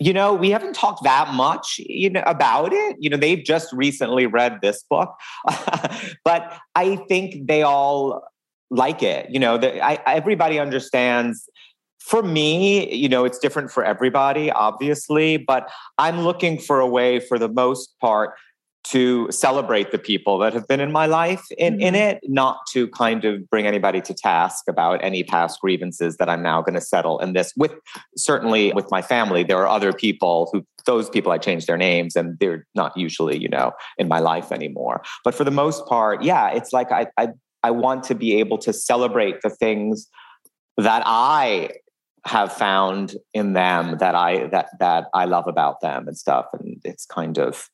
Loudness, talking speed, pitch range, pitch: -20 LUFS, 185 wpm, 105-165 Hz, 130 Hz